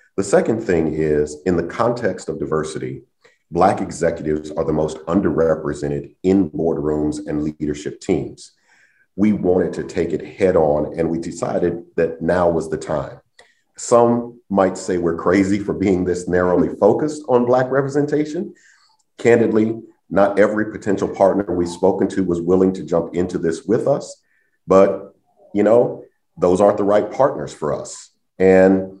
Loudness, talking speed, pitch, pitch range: -18 LUFS, 155 wpm, 90 Hz, 80-100 Hz